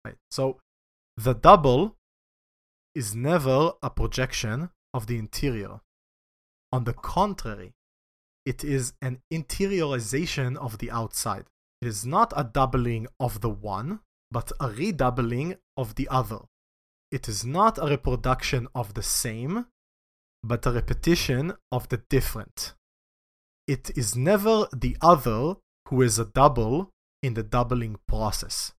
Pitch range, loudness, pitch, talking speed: 110-140 Hz, -26 LUFS, 125 Hz, 130 wpm